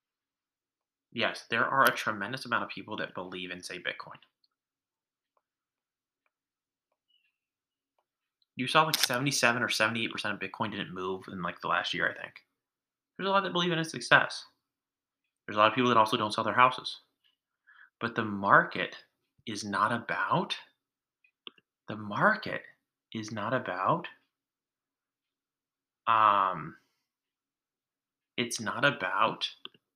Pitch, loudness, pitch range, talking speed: 120 Hz, -29 LUFS, 110-130 Hz, 130 wpm